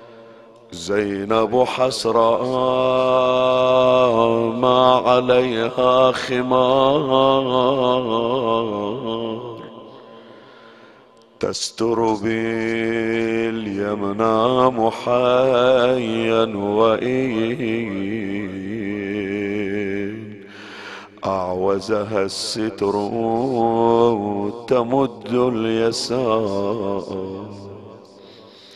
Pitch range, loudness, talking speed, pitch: 105-125 Hz, -19 LUFS, 25 wpm, 115 Hz